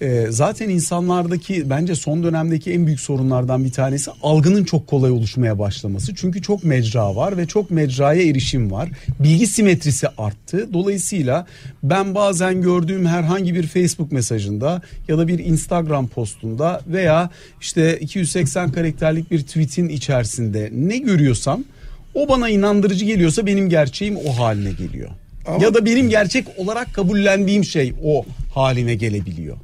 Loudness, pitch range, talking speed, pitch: -18 LUFS, 130-185 Hz, 140 wpm, 160 Hz